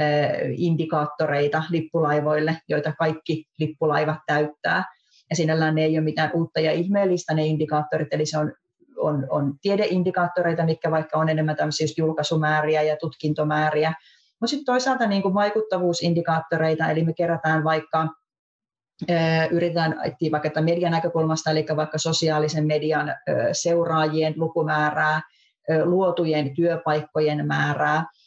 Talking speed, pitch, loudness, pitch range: 115 wpm, 160 Hz, -23 LUFS, 155-170 Hz